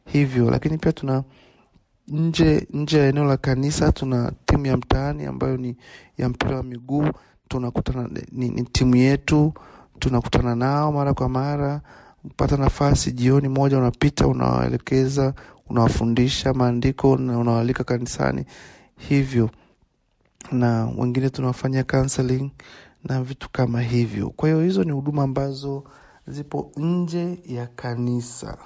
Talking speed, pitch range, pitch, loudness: 120 wpm, 120-140 Hz, 130 Hz, -22 LUFS